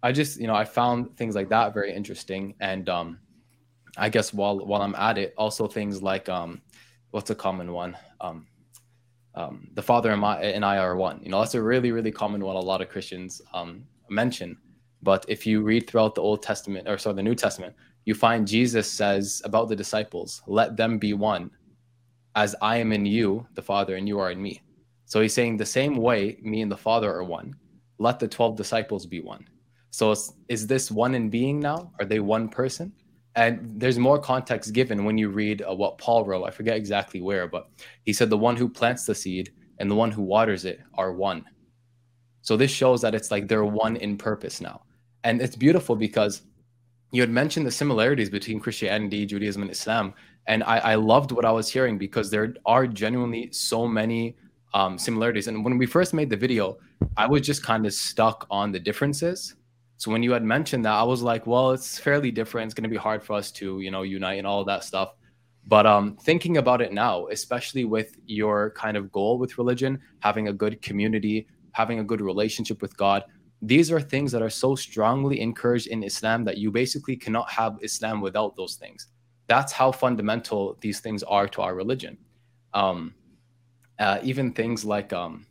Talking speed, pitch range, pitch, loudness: 205 wpm, 105-120 Hz, 110 Hz, -25 LUFS